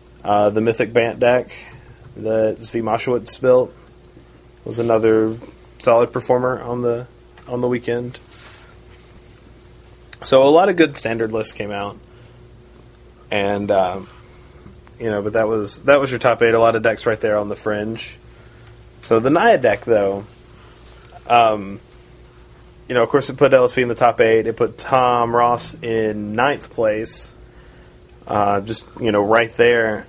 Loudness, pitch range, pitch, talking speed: -17 LUFS, 105-120 Hz, 115 Hz, 155 wpm